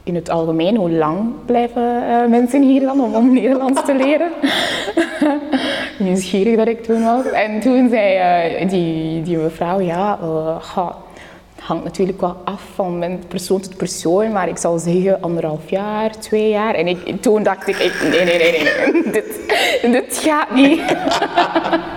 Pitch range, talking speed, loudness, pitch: 180-255 Hz, 170 wpm, -16 LUFS, 215 Hz